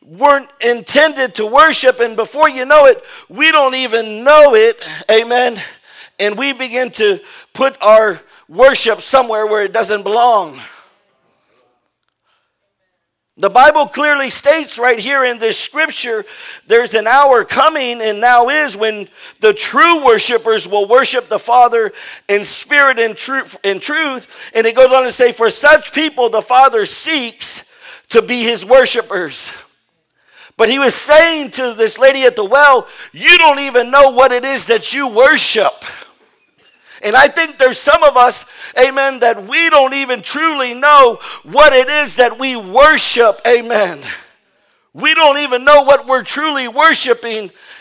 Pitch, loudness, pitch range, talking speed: 255 Hz, -11 LUFS, 230-290 Hz, 150 wpm